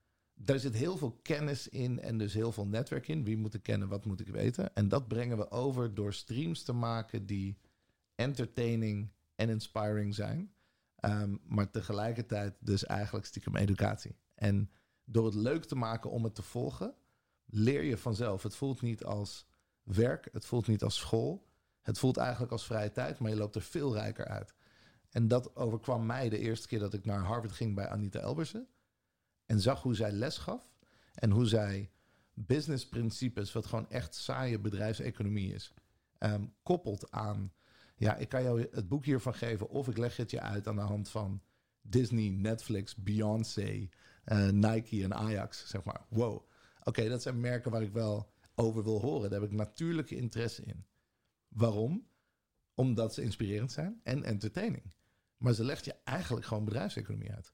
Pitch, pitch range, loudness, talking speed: 110 Hz, 105-125 Hz, -36 LUFS, 180 wpm